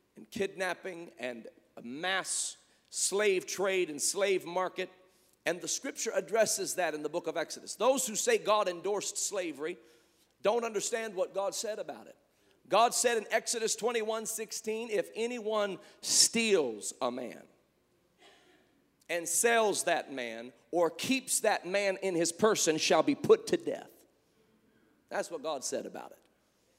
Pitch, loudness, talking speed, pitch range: 200 Hz, -31 LUFS, 145 wpm, 175-230 Hz